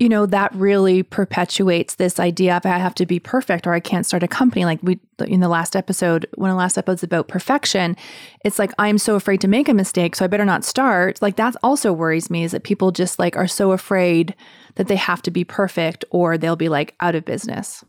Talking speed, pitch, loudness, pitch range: 240 wpm, 185 Hz, -18 LUFS, 175-205 Hz